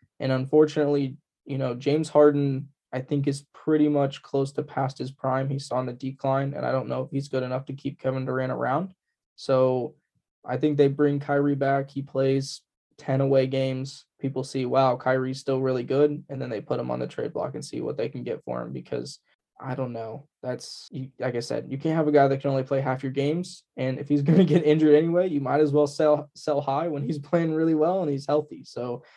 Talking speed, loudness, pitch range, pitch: 230 wpm, -25 LUFS, 130-150 Hz, 140 Hz